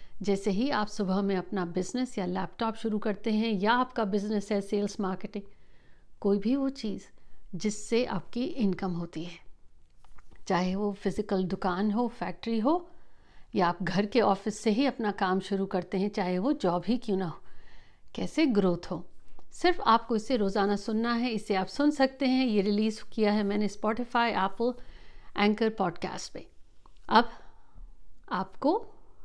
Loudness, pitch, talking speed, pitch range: -29 LUFS, 210 Hz, 160 wpm, 190-230 Hz